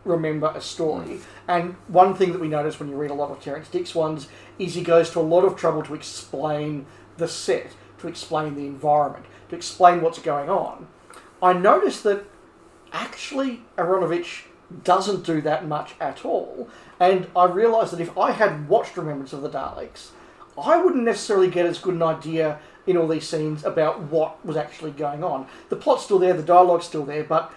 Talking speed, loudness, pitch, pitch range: 195 wpm, -22 LUFS, 165 Hz, 155-180 Hz